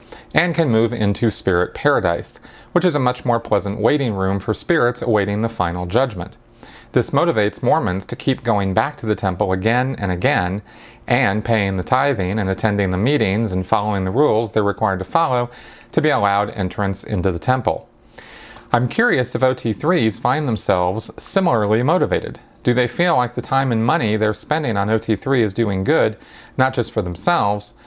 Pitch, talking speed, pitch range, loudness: 110 Hz, 180 wpm, 100-125 Hz, -19 LUFS